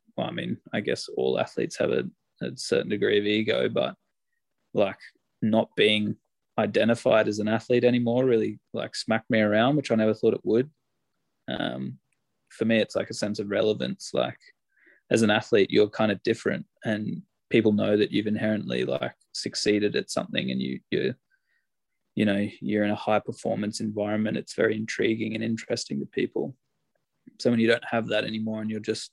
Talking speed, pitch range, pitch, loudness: 185 wpm, 105-115 Hz, 110 Hz, -26 LUFS